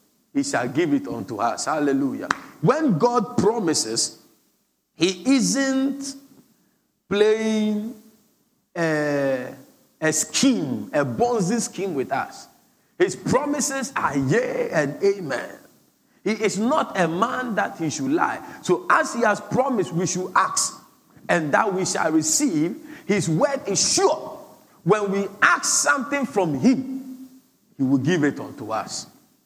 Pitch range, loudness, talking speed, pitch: 190-275 Hz, -22 LUFS, 130 wpm, 230 Hz